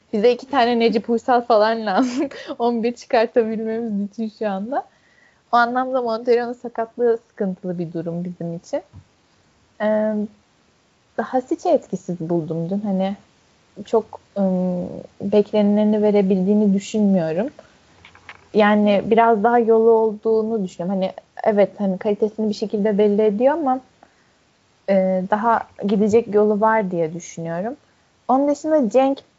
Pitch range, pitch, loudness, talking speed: 200-235 Hz, 220 Hz, -20 LUFS, 120 wpm